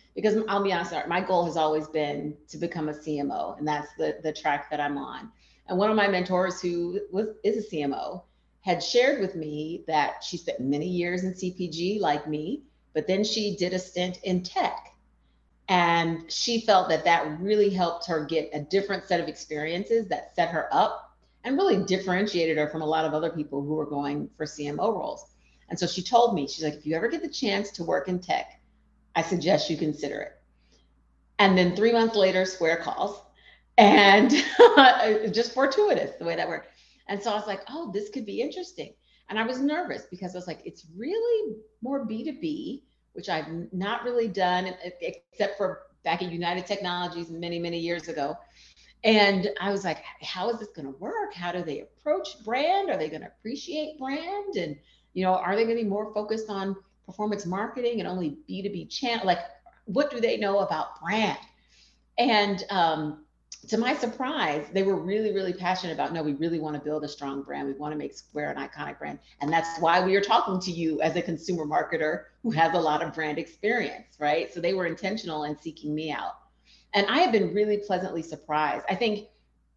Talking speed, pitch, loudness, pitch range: 200 wpm, 180 Hz, -26 LUFS, 155-215 Hz